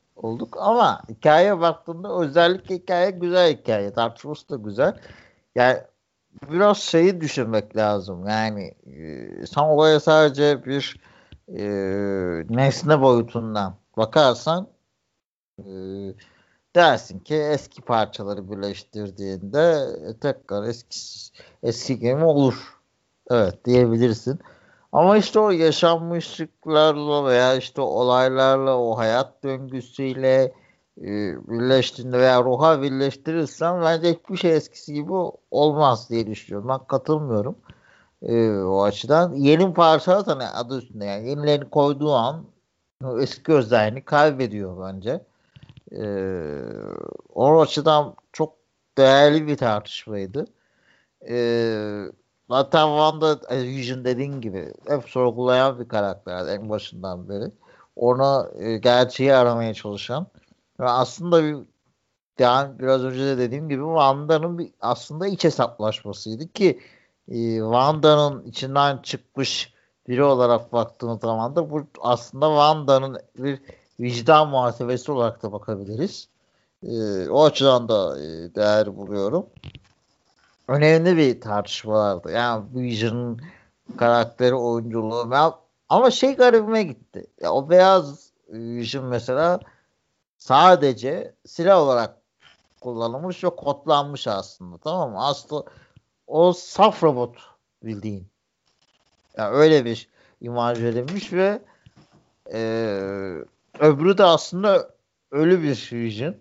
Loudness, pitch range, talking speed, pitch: -21 LUFS, 115-155 Hz, 110 wpm, 130 Hz